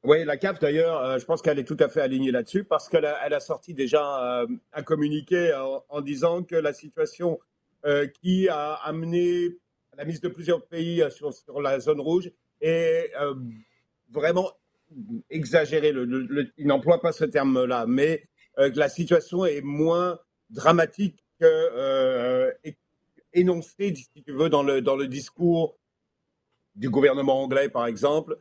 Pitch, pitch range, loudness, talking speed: 160 Hz, 145-180 Hz, -25 LUFS, 165 wpm